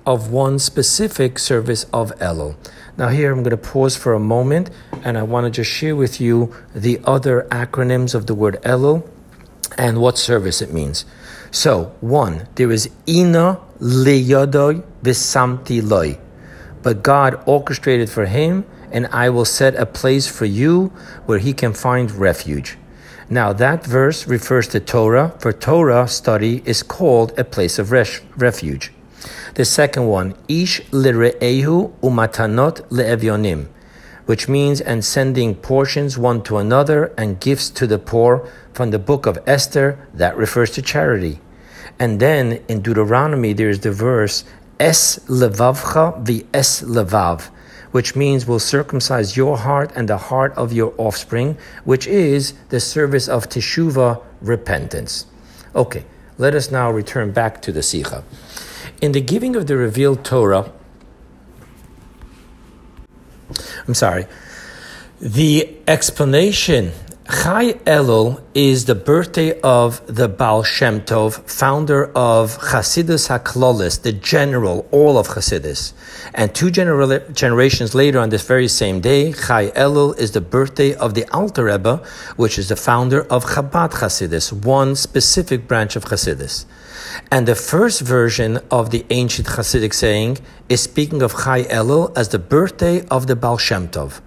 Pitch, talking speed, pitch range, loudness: 125 Hz, 145 wpm, 110-140 Hz, -16 LUFS